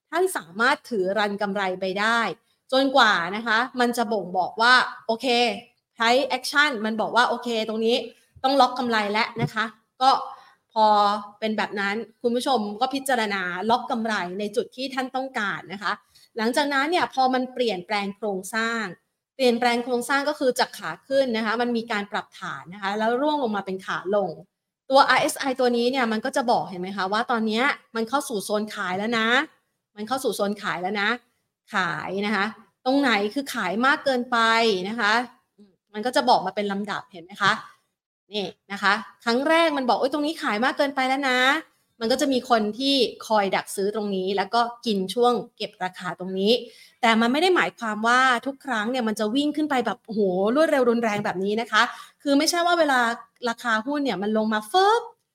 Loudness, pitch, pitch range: -23 LUFS, 230 Hz, 205-255 Hz